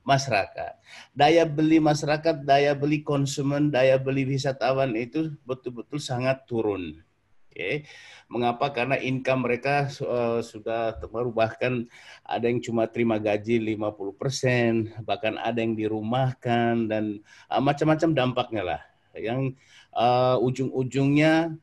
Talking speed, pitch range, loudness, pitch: 110 wpm, 115-140 Hz, -25 LUFS, 125 Hz